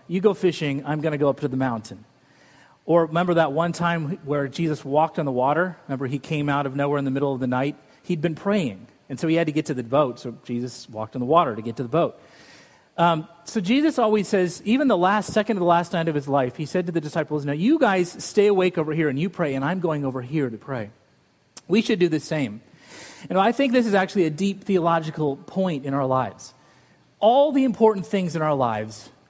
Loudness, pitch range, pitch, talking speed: -23 LUFS, 140-185 Hz, 160 Hz, 250 wpm